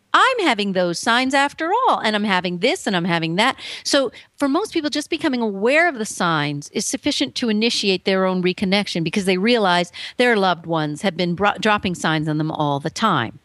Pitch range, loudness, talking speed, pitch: 175-265 Hz, -19 LUFS, 210 wpm, 205 Hz